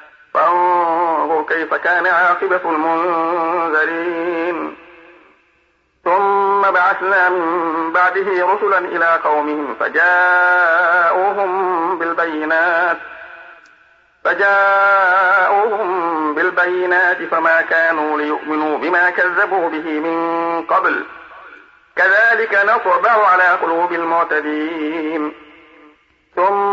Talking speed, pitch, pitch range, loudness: 65 wpm, 170 Hz, 165-185 Hz, -15 LUFS